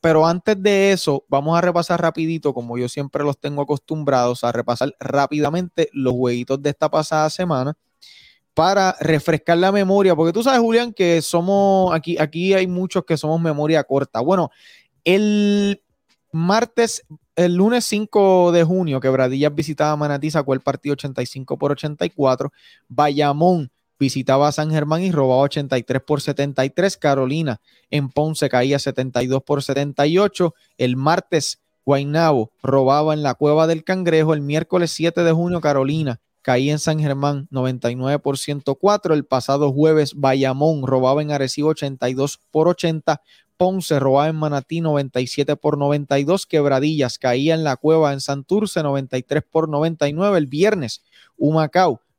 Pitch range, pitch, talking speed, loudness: 140-170 Hz, 150 Hz, 145 wpm, -19 LUFS